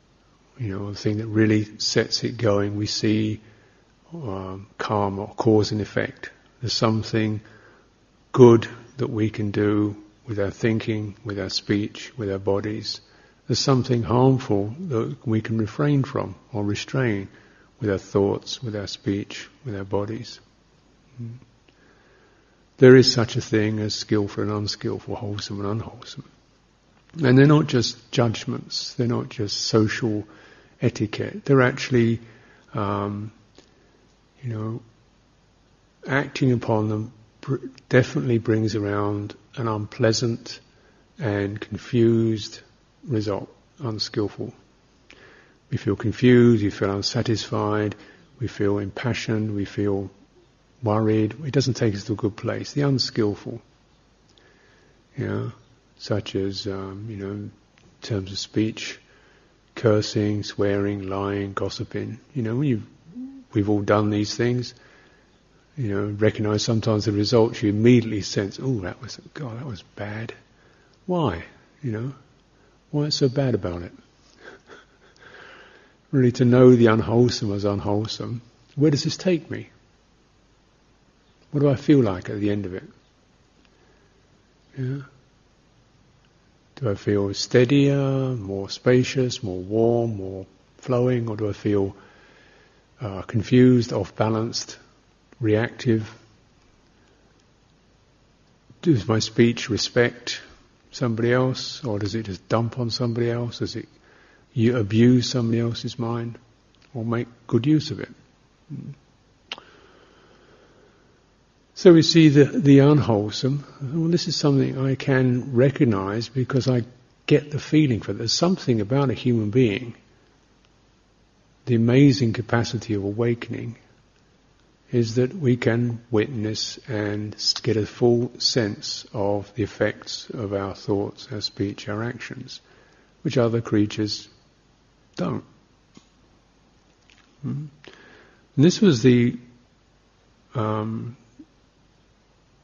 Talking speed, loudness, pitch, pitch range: 120 wpm, -23 LUFS, 115 Hz, 105-125 Hz